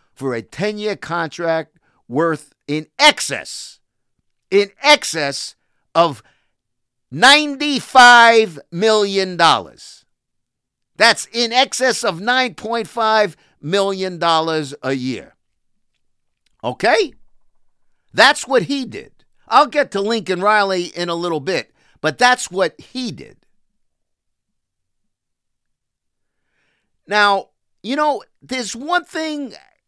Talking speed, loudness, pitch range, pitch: 90 wpm, -16 LUFS, 165-250 Hz, 205 Hz